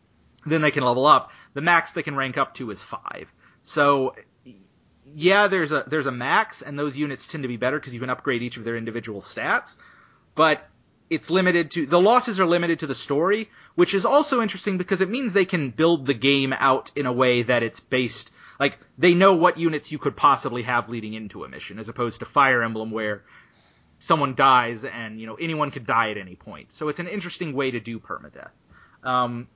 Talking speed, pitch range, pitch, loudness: 215 wpm, 120-170 Hz, 140 Hz, -22 LUFS